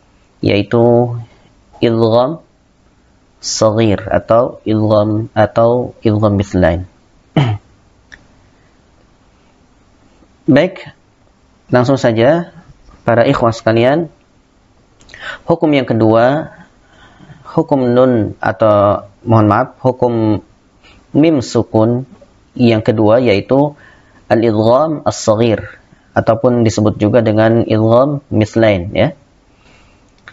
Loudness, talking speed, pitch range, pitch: -13 LUFS, 70 wpm, 105-125 Hz, 115 Hz